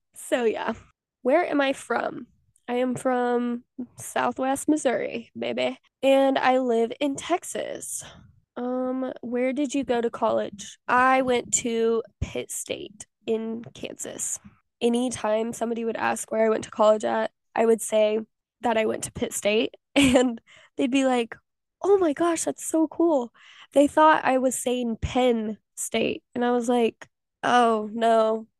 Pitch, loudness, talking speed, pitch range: 245 Hz, -24 LUFS, 155 wpm, 225-270 Hz